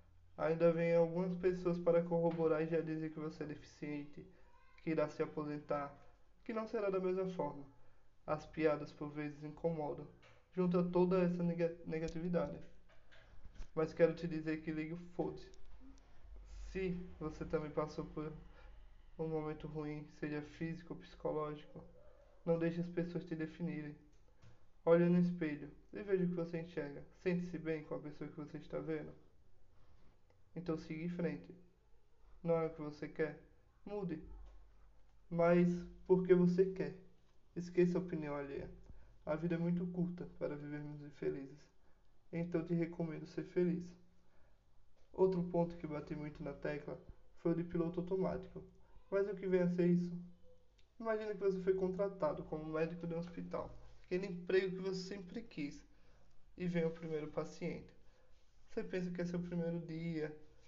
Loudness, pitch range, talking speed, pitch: -40 LUFS, 150-175 Hz, 155 wpm, 165 Hz